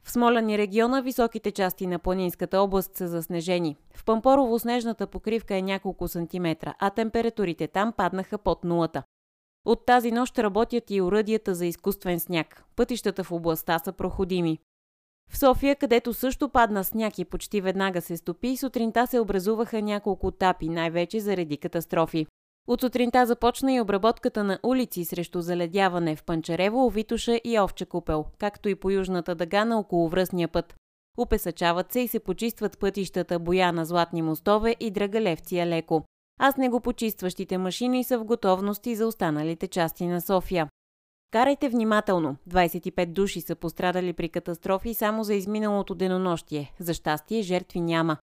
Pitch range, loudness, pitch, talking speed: 175-225 Hz, -26 LUFS, 190 Hz, 150 wpm